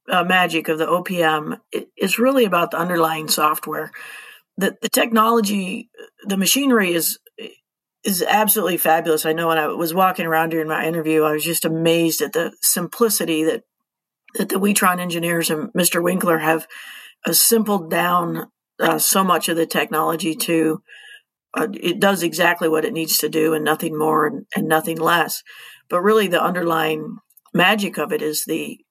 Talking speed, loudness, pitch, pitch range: 170 wpm, -18 LUFS, 170 Hz, 160-195 Hz